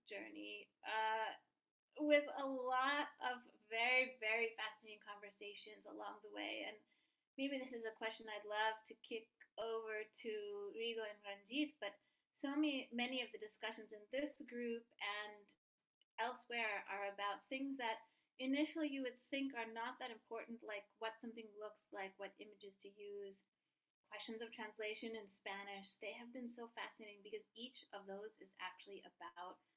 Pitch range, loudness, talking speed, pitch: 210-255 Hz, -46 LUFS, 155 wpm, 225 Hz